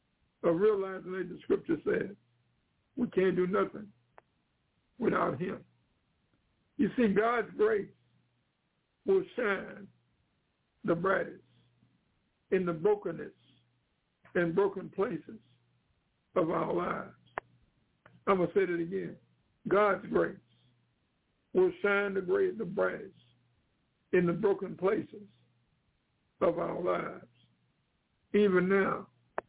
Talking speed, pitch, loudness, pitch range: 100 wpm, 195 Hz, -31 LUFS, 175-210 Hz